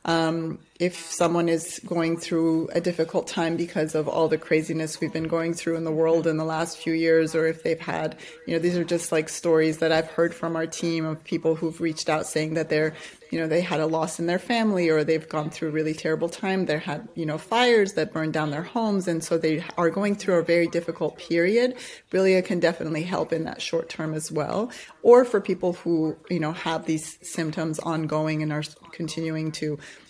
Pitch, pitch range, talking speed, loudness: 165 Hz, 160-170 Hz, 225 wpm, -25 LUFS